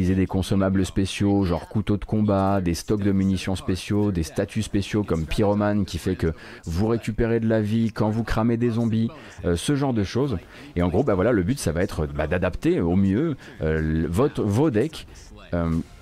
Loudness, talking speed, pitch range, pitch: -24 LUFS, 205 wpm, 90-110 Hz, 100 Hz